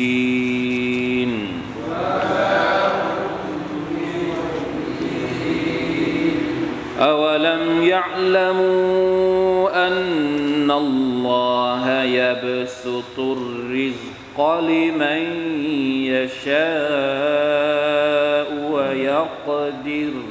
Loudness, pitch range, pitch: -20 LUFS, 130-165 Hz, 145 Hz